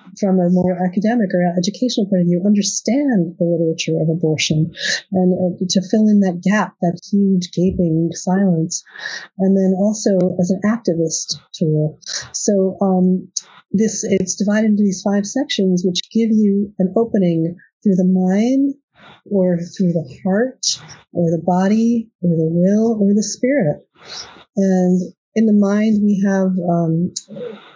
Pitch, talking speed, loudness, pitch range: 190 Hz, 150 wpm, -17 LUFS, 175-210 Hz